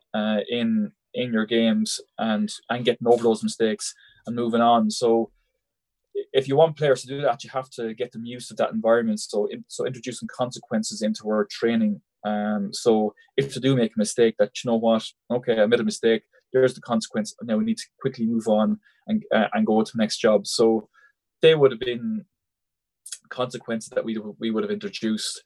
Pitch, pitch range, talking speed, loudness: 115 Hz, 110-140 Hz, 205 wpm, -24 LUFS